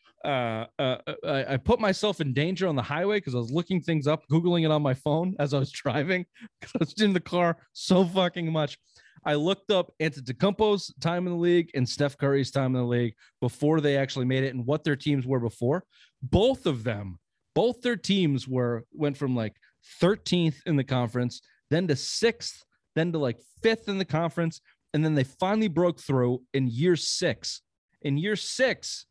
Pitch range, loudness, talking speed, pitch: 135-180 Hz, -27 LUFS, 200 wpm, 155 Hz